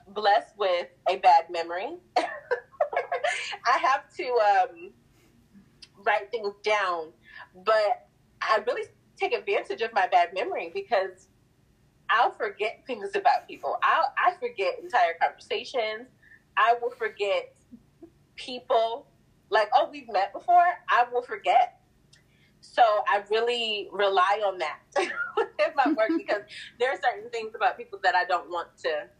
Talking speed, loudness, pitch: 135 wpm, -26 LUFS, 250 Hz